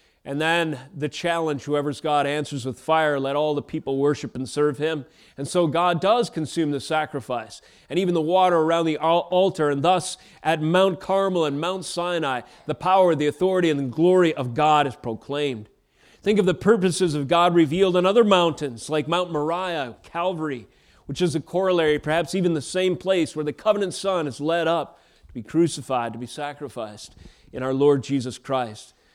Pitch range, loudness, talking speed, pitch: 145-175 Hz, -23 LUFS, 185 wpm, 155 Hz